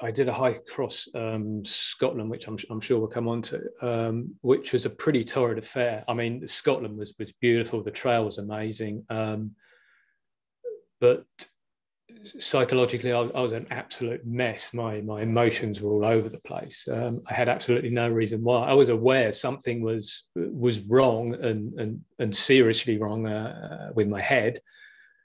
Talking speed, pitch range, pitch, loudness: 170 wpm, 110-125 Hz, 115 Hz, -26 LUFS